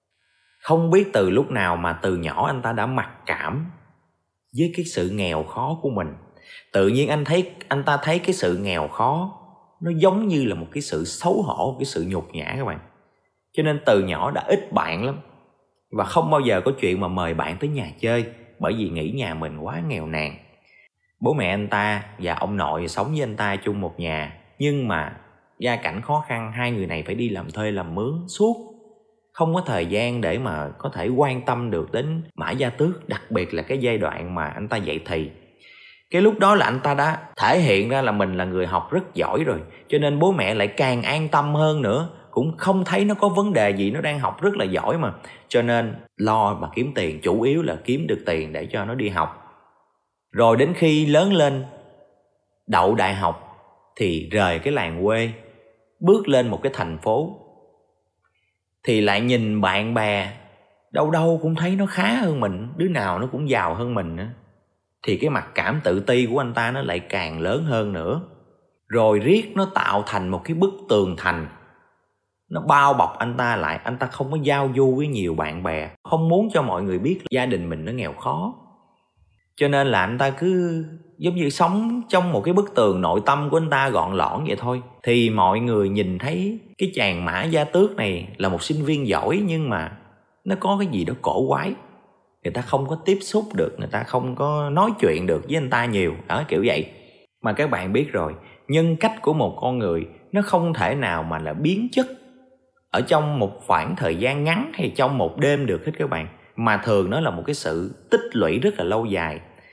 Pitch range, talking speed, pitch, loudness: 100-165 Hz, 220 wpm, 125 Hz, -22 LUFS